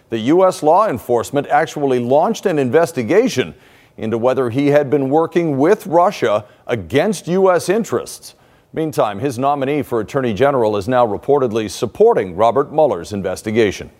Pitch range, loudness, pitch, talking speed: 120-155 Hz, -16 LUFS, 140 Hz, 135 wpm